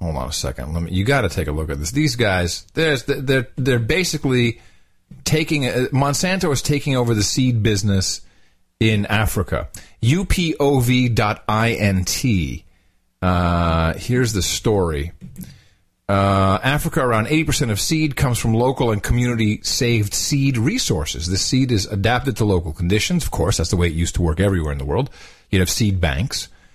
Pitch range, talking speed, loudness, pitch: 90-130 Hz, 175 wpm, -19 LUFS, 105 Hz